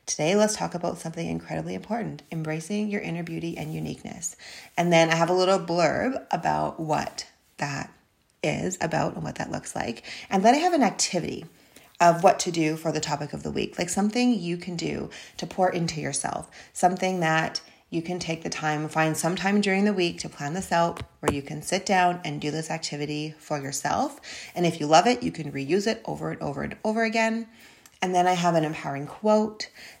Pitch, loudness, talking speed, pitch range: 170 Hz, -26 LUFS, 210 wpm, 155-195 Hz